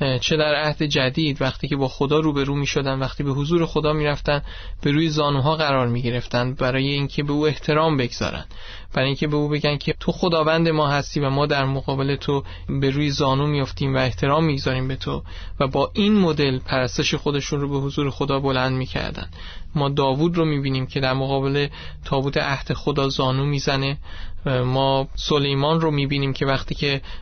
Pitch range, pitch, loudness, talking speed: 130-150 Hz, 140 Hz, -21 LUFS, 195 wpm